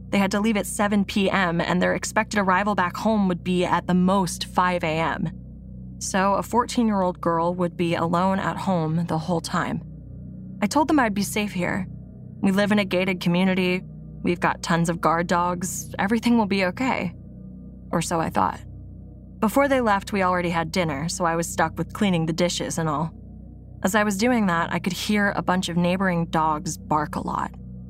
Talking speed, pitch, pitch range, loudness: 200 wpm, 180 Hz, 165-200 Hz, -23 LUFS